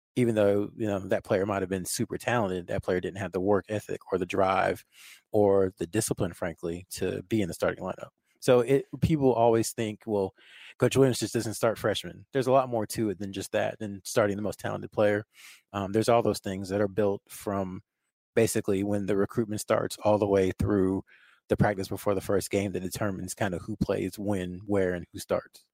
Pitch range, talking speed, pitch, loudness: 95-110 Hz, 215 wpm, 100 Hz, -28 LUFS